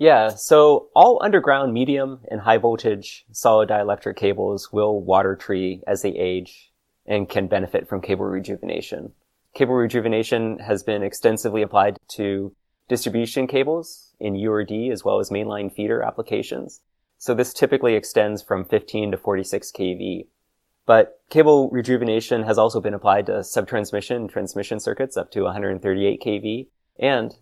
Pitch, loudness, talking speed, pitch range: 110 Hz, -21 LUFS, 145 wpm, 100-125 Hz